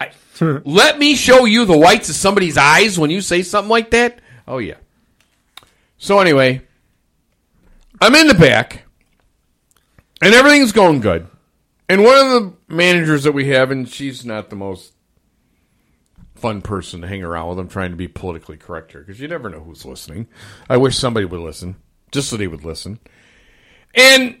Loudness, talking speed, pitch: -12 LUFS, 175 wpm, 130 Hz